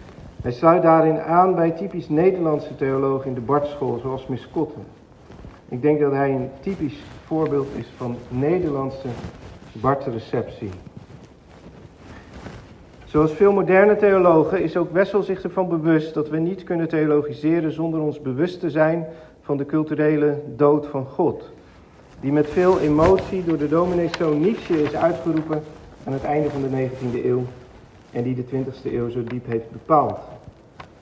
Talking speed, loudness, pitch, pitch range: 145 wpm, -21 LUFS, 150 Hz, 130-165 Hz